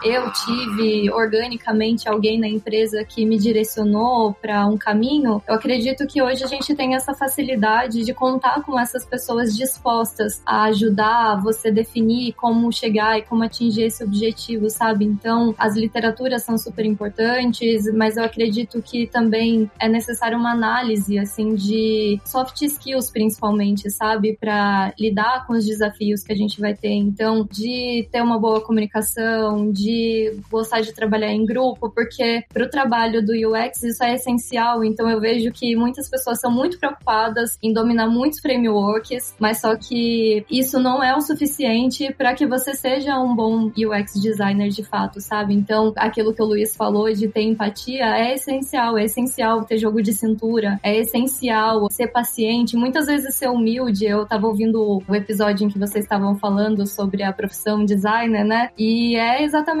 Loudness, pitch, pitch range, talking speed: -19 LUFS, 225 Hz, 215-240 Hz, 165 wpm